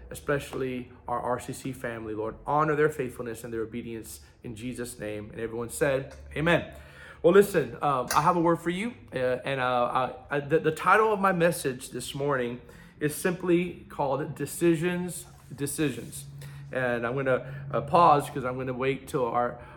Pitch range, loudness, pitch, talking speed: 120-150 Hz, -28 LUFS, 135 Hz, 175 wpm